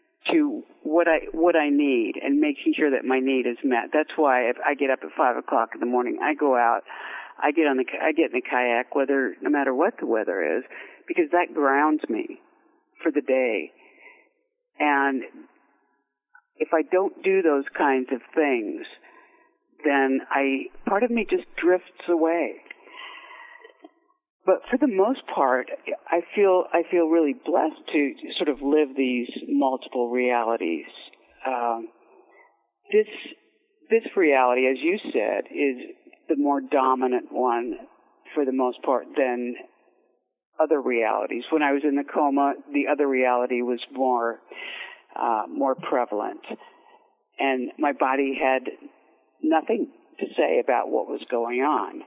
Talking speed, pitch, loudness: 155 wpm, 160 Hz, -24 LUFS